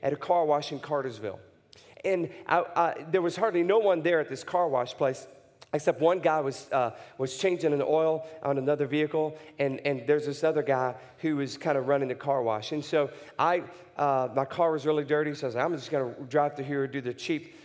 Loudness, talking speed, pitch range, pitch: -28 LUFS, 235 wpm, 135-165 Hz, 150 Hz